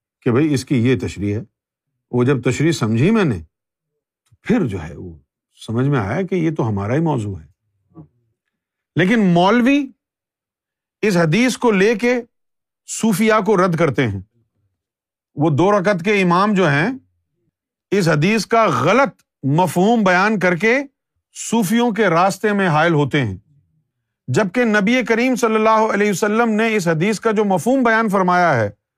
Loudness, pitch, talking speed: -17 LUFS, 175 Hz, 160 wpm